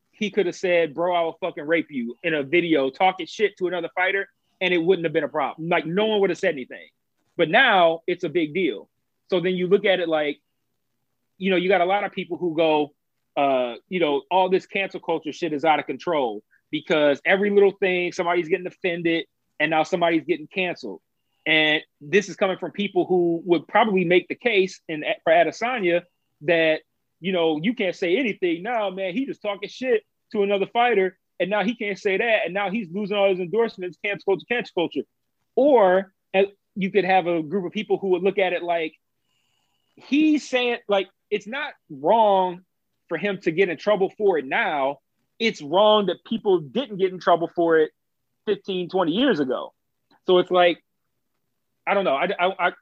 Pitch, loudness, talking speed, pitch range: 185 Hz, -22 LUFS, 205 wpm, 170-200 Hz